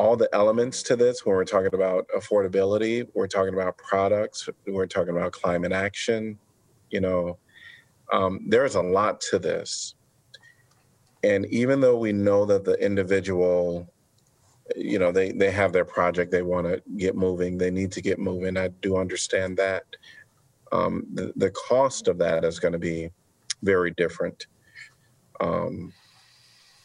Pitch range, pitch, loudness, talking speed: 95-135 Hz, 100 Hz, -25 LUFS, 155 wpm